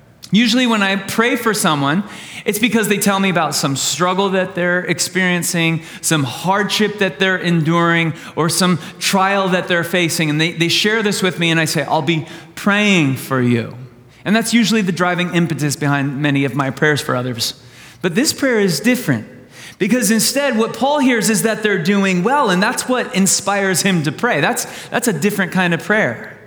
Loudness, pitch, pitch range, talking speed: -16 LUFS, 185 Hz, 160-205 Hz, 195 wpm